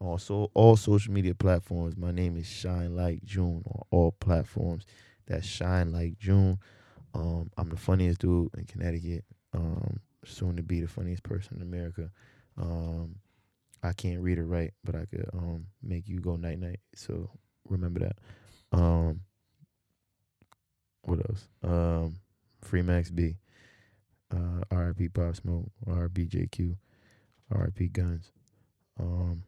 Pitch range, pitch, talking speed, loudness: 85-105 Hz, 90 Hz, 140 wpm, -31 LUFS